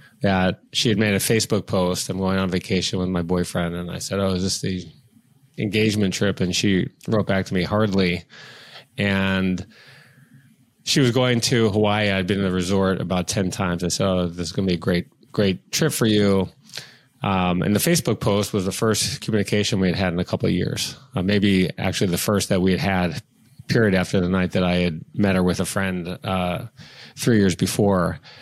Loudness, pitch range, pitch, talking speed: -21 LUFS, 90-110 Hz, 95 Hz, 210 wpm